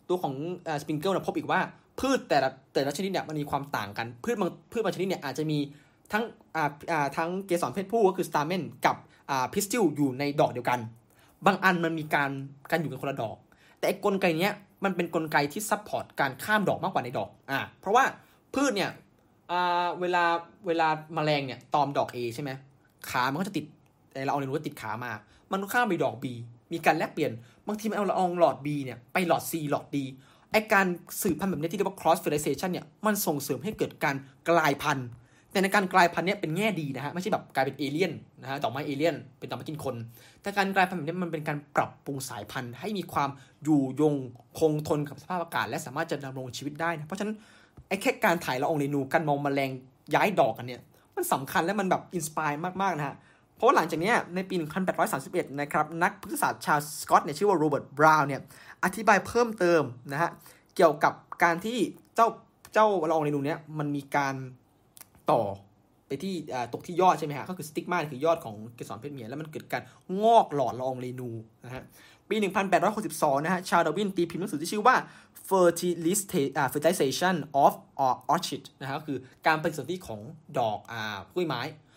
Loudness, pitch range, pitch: -28 LUFS, 140-180 Hz, 155 Hz